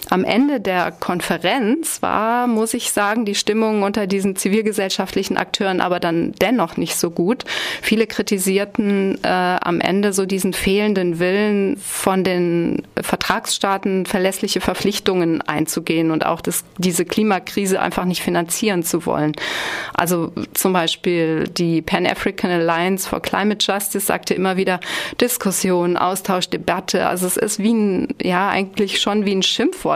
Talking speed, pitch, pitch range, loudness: 140 wpm, 195 Hz, 180-205 Hz, -19 LUFS